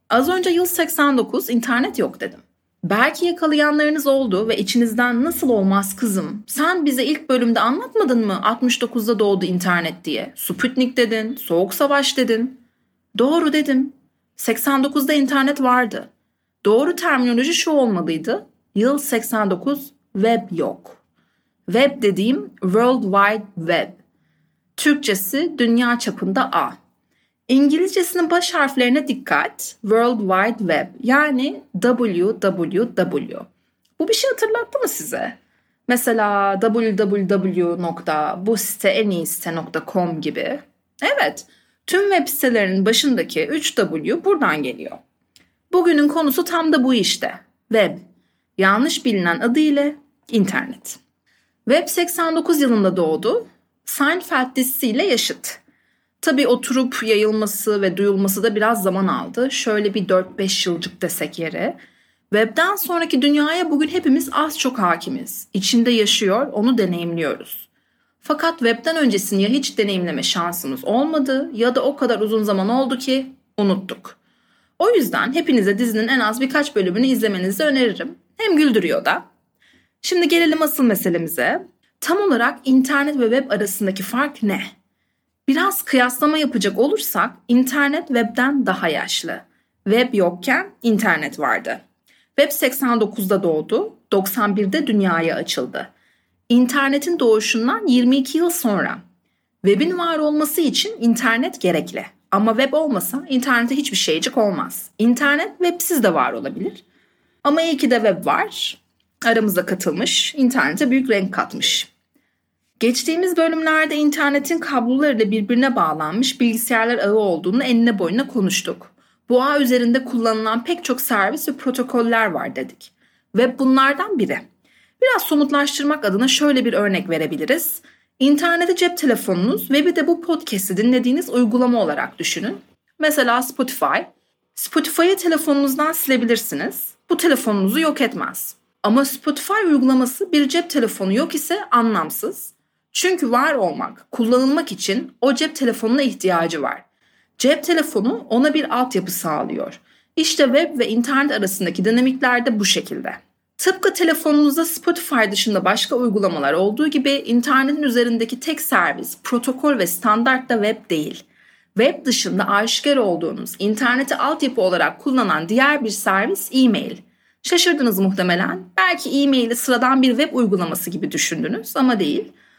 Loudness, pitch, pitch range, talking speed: -18 LUFS, 250 Hz, 210-290 Hz, 120 wpm